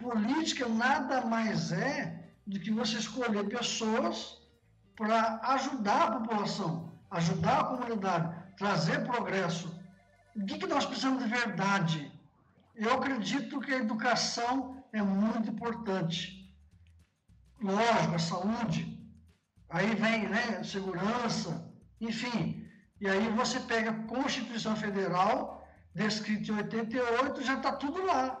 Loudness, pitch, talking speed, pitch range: -32 LUFS, 220 Hz, 115 wpm, 190-240 Hz